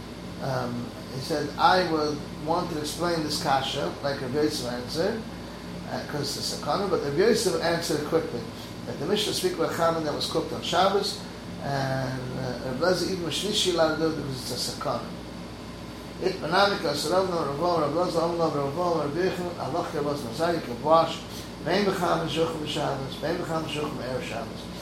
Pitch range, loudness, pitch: 125-170 Hz, -27 LUFS, 150 Hz